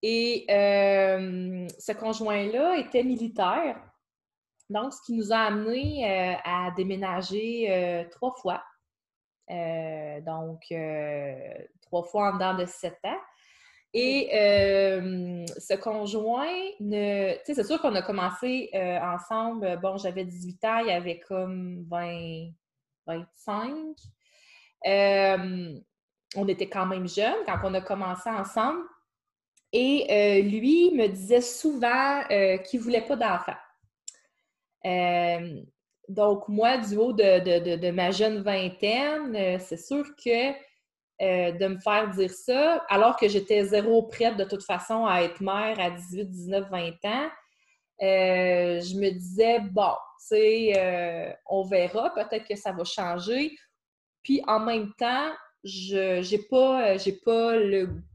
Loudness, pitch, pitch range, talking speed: -26 LUFS, 200 Hz, 180-230 Hz, 140 wpm